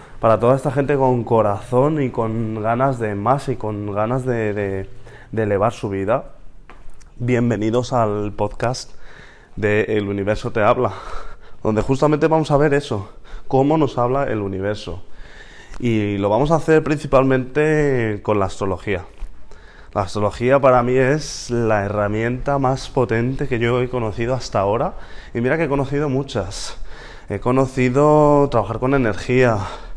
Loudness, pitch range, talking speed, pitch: -19 LUFS, 105-135 Hz, 150 wpm, 120 Hz